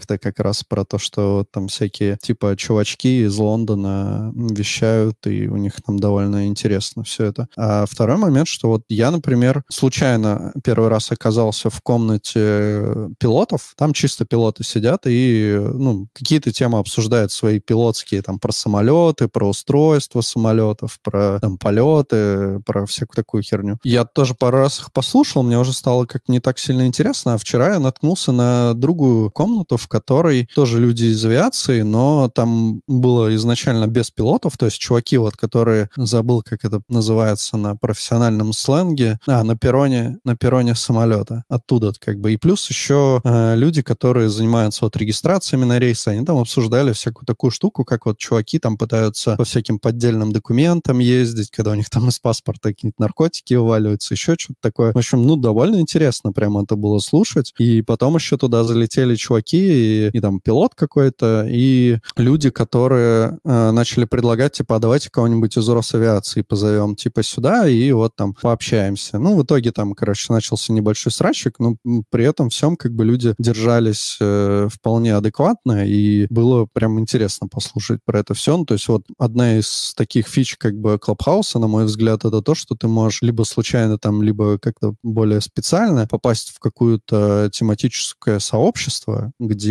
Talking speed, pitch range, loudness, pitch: 170 wpm, 110-125 Hz, -17 LUFS, 115 Hz